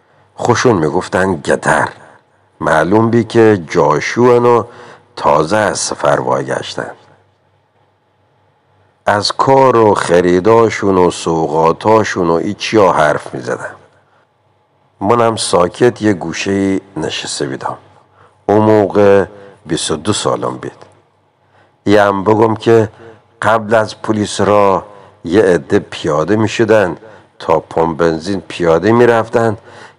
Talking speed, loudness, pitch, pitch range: 105 wpm, -13 LUFS, 105 Hz, 95-115 Hz